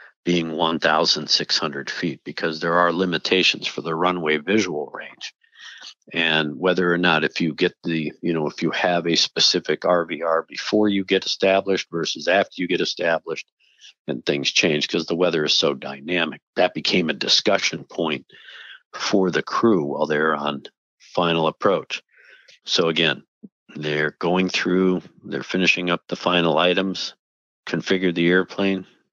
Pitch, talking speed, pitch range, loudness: 90 Hz, 150 wpm, 80-95 Hz, -21 LUFS